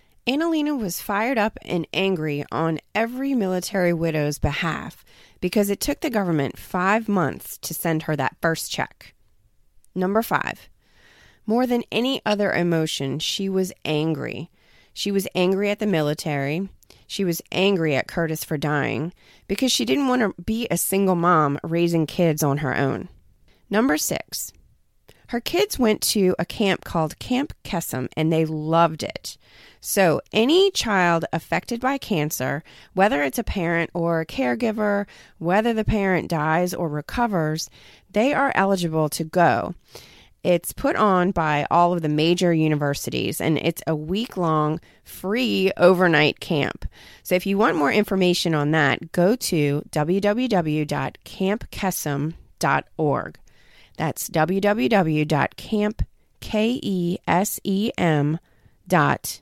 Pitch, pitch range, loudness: 175 Hz, 155-205 Hz, -22 LUFS